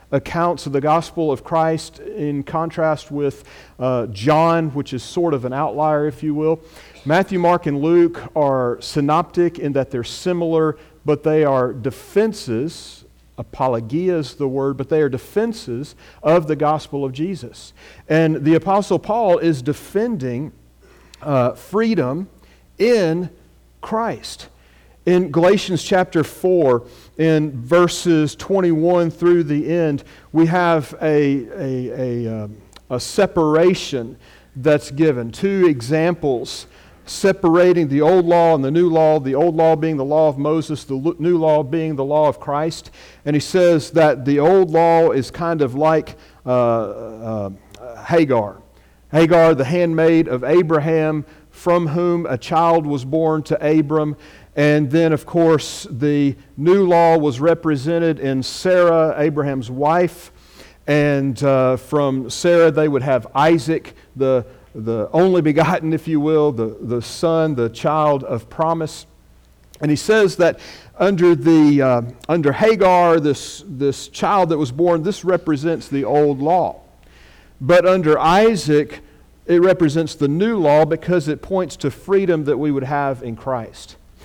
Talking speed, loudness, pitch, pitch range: 145 wpm, -17 LUFS, 155 Hz, 135-170 Hz